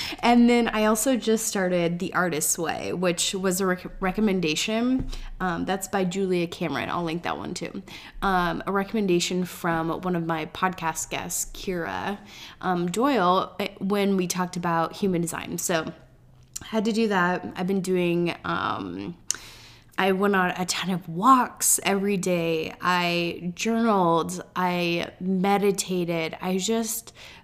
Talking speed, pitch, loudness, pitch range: 145 wpm, 185 Hz, -25 LUFS, 170-200 Hz